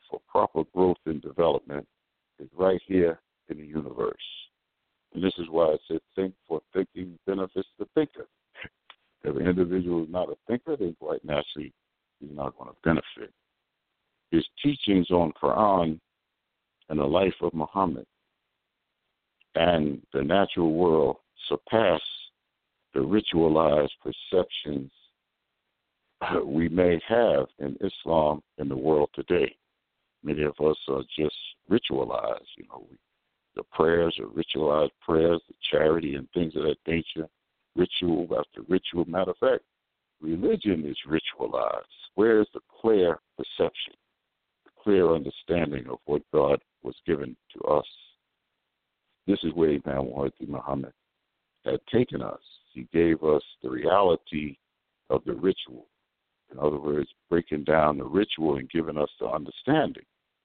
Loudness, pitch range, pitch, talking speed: -27 LUFS, 75-90 Hz, 80 Hz, 135 wpm